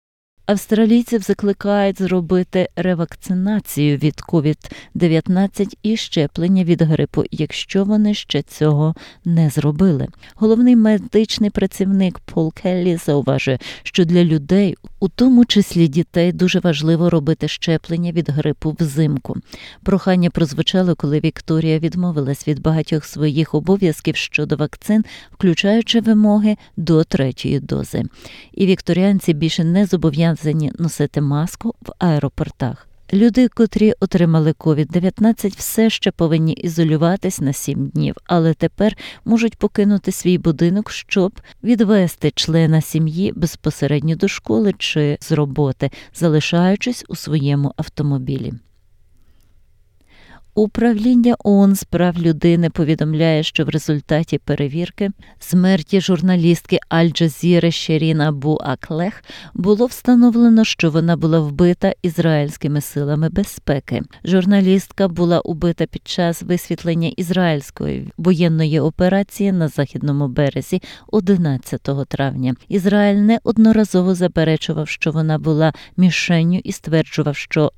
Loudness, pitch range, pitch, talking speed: -17 LUFS, 155-195 Hz, 170 Hz, 110 wpm